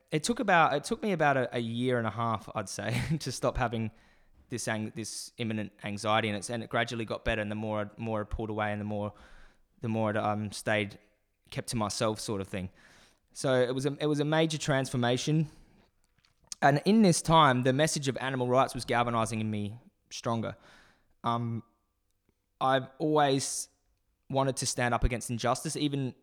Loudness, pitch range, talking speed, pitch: -30 LUFS, 105-135 Hz, 190 wpm, 120 Hz